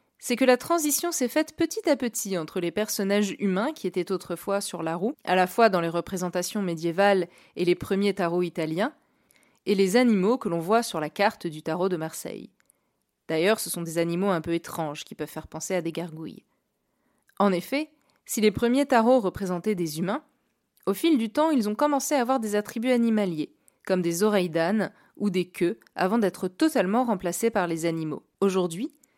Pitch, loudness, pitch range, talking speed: 200 Hz, -26 LUFS, 175-235 Hz, 195 wpm